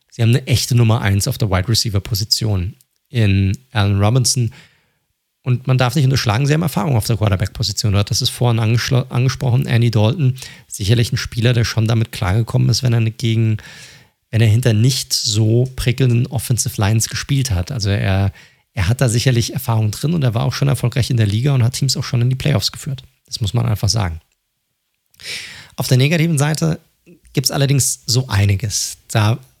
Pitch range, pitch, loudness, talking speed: 110-130 Hz, 120 Hz, -17 LUFS, 185 wpm